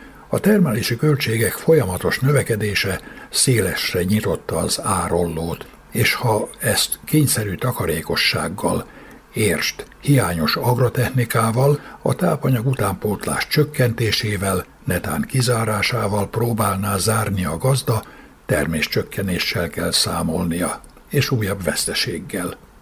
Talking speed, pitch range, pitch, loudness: 90 wpm, 100-130 Hz, 115 Hz, -20 LUFS